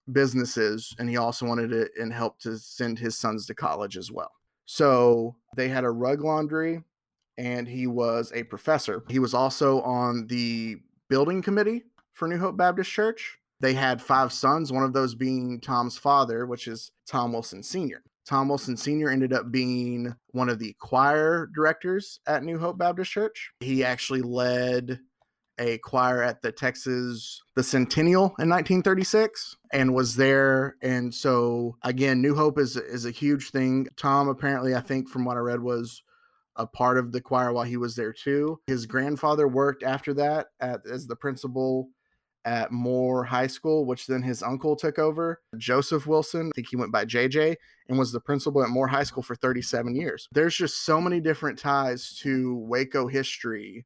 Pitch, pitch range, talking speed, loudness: 130 Hz, 120-145 Hz, 180 wpm, -26 LUFS